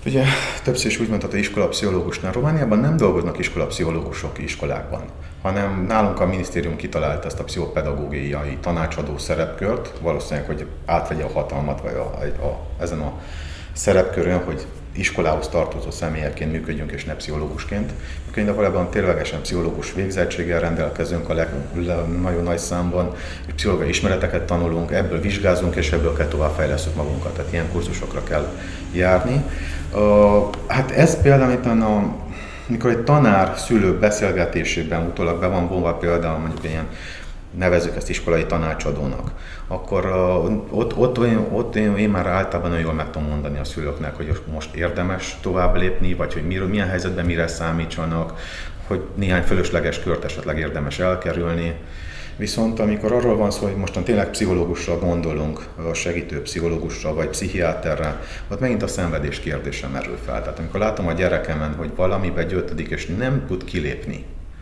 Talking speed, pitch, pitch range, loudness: 150 wpm, 85 Hz, 80-95 Hz, -22 LUFS